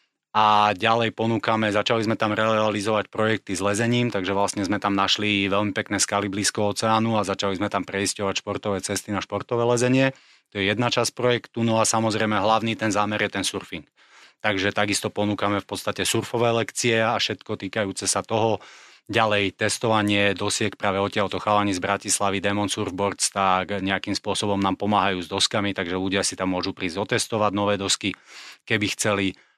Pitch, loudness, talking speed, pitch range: 105 Hz, -23 LUFS, 170 wpm, 100-110 Hz